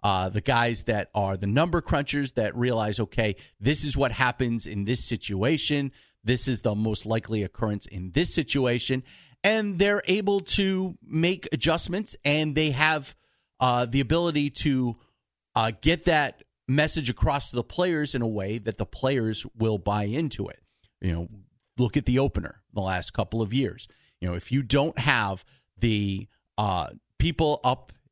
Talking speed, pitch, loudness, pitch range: 170 wpm, 125 Hz, -26 LUFS, 110-150 Hz